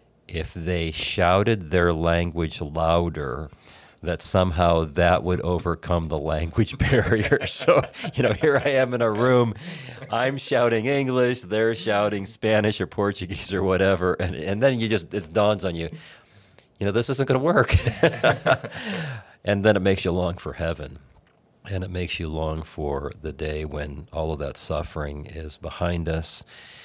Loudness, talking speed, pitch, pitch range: -23 LUFS, 165 wpm, 95 Hz, 85-115 Hz